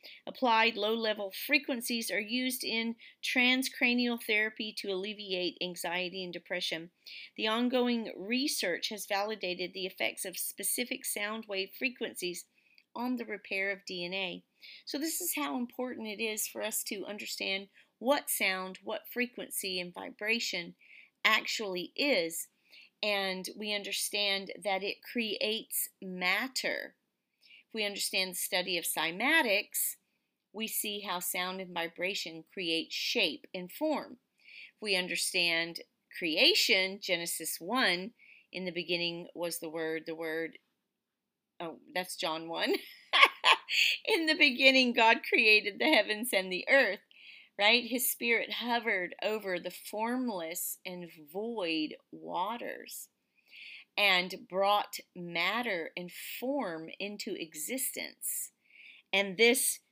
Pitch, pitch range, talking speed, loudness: 210 Hz, 180-250 Hz, 120 wpm, -31 LUFS